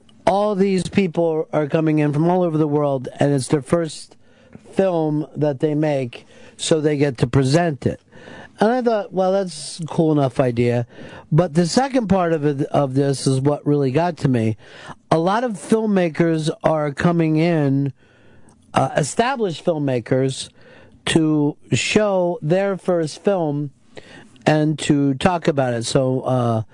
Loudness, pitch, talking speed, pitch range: -19 LUFS, 155 Hz, 155 wpm, 140-175 Hz